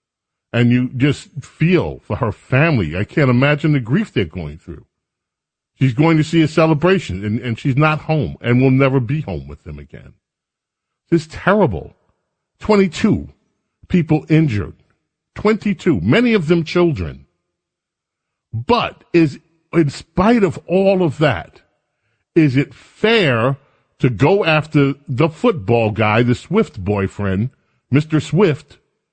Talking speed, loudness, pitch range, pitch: 140 wpm, -16 LUFS, 120-165 Hz, 145 Hz